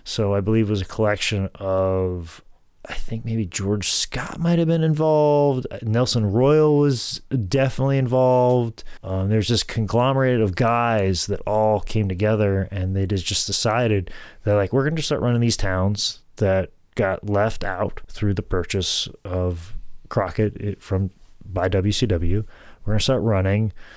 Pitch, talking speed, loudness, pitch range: 105 Hz, 150 wpm, -21 LUFS, 95-120 Hz